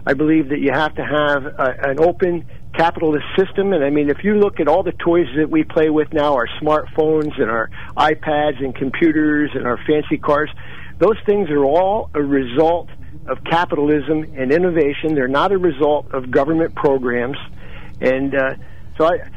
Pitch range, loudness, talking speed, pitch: 140-160 Hz, -17 LUFS, 185 wpm, 150 Hz